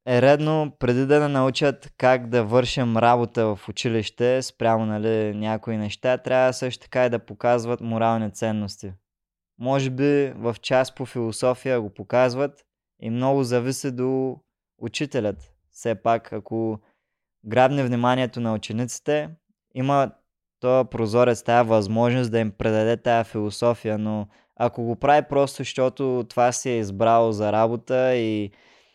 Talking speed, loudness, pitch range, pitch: 140 wpm, -23 LUFS, 110-130 Hz, 120 Hz